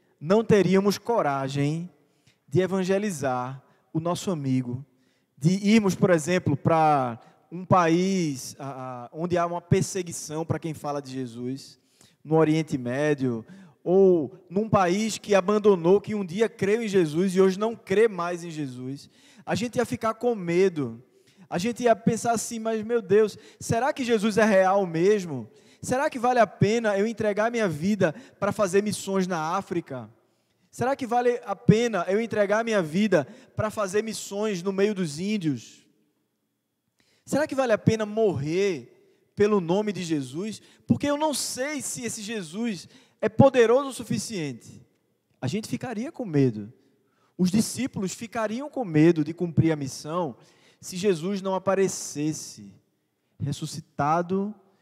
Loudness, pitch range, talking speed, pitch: -25 LUFS, 155-215 Hz, 150 wpm, 190 Hz